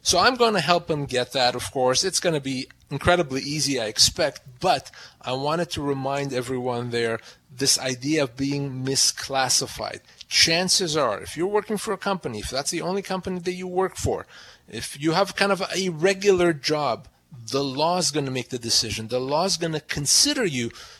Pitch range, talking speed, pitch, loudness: 130-180 Hz, 195 wpm, 145 Hz, -23 LUFS